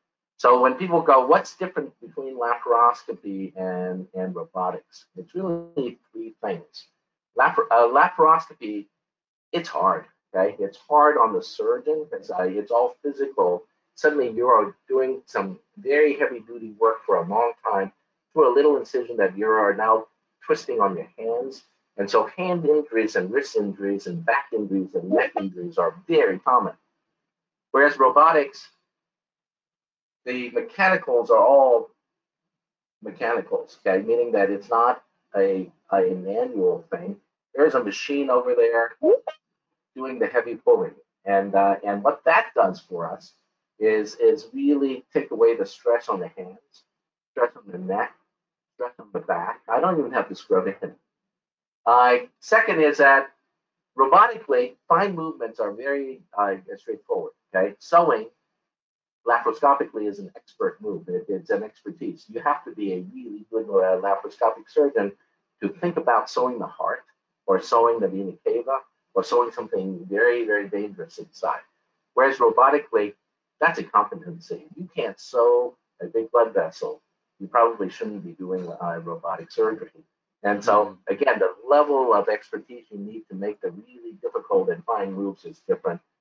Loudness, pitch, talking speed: -22 LUFS, 170 Hz, 155 wpm